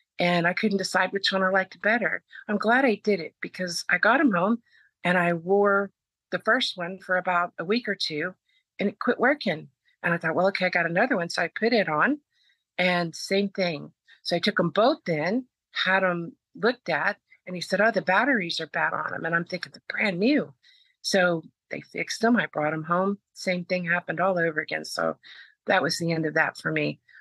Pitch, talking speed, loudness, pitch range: 185 Hz, 225 wpm, -25 LUFS, 170-210 Hz